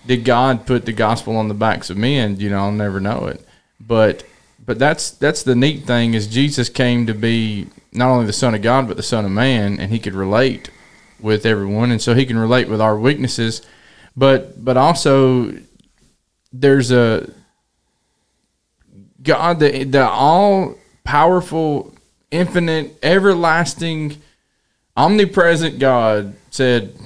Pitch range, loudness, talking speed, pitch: 110-140 Hz, -16 LUFS, 150 wpm, 125 Hz